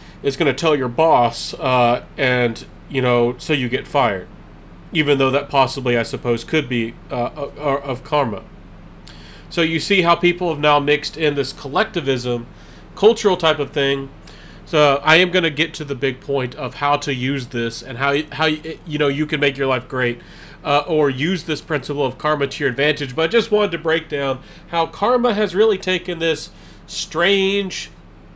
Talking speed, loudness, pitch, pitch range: 195 wpm, -19 LUFS, 145 Hz, 135-165 Hz